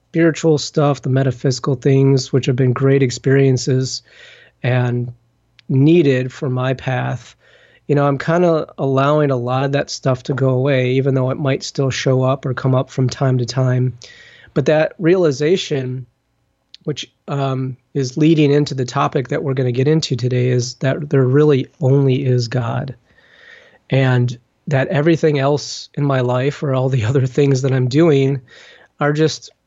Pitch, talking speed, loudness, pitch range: 135 Hz, 170 wpm, -17 LUFS, 130-145 Hz